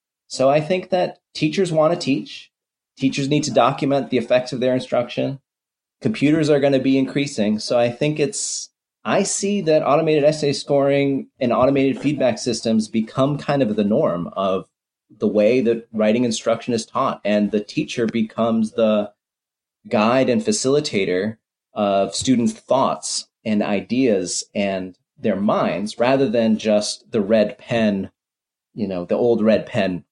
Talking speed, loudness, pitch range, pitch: 155 wpm, -20 LUFS, 110-145 Hz, 125 Hz